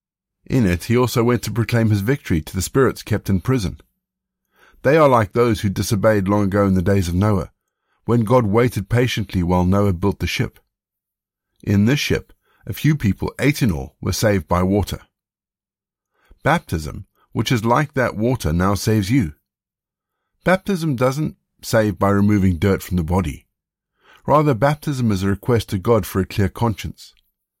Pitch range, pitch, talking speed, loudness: 95-125 Hz, 105 Hz, 170 wpm, -19 LUFS